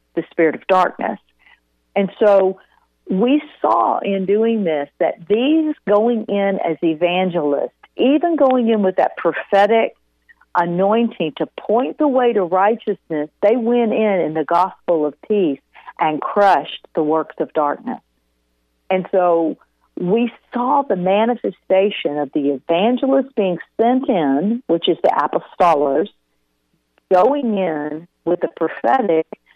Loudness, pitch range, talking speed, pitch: -18 LUFS, 160-230 Hz, 130 wpm, 190 Hz